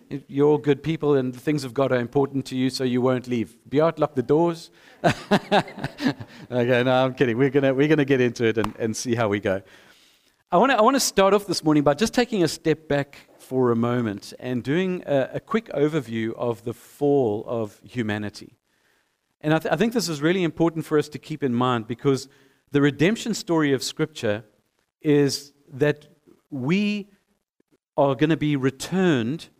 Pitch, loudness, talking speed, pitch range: 140 Hz, -23 LUFS, 195 wpm, 125-155 Hz